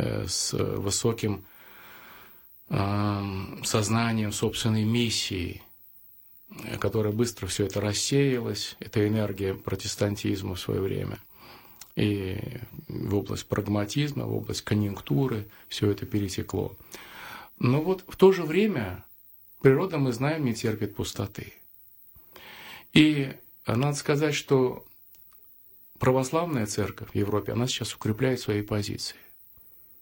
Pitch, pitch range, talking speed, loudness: 110 Hz, 105-125 Hz, 100 wpm, -27 LUFS